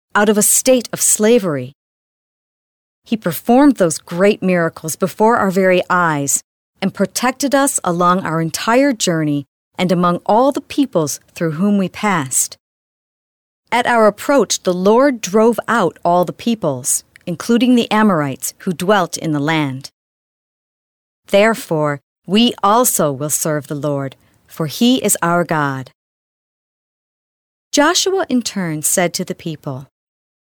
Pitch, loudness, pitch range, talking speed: 185 Hz, -15 LUFS, 160-225 Hz, 135 wpm